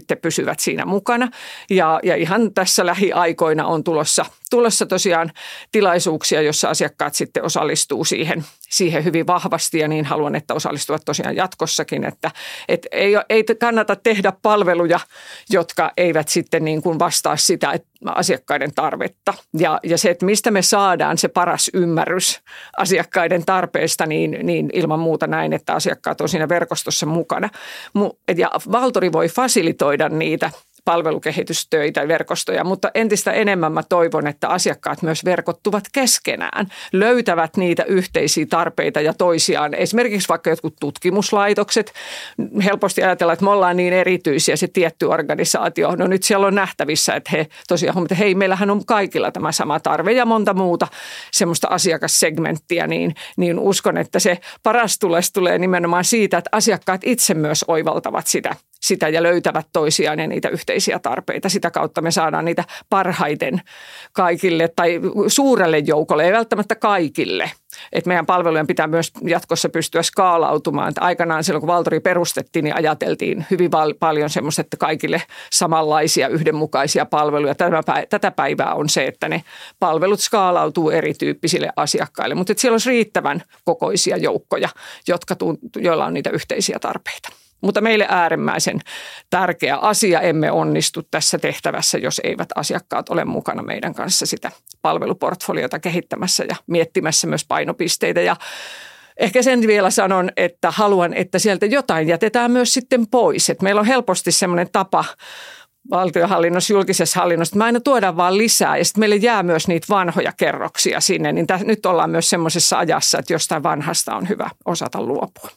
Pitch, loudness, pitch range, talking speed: 180 Hz, -18 LUFS, 165-205 Hz, 150 wpm